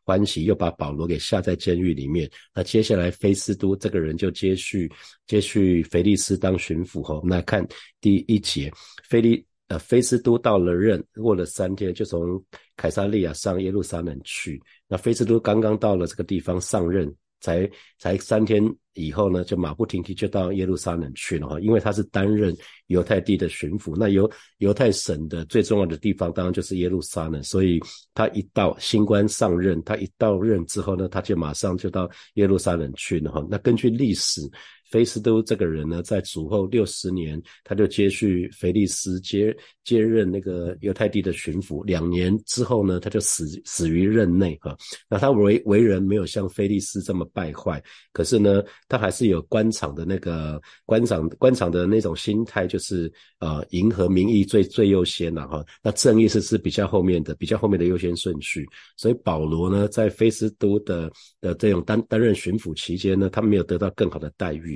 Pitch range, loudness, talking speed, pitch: 85-105 Hz, -23 LUFS, 290 characters per minute, 95 Hz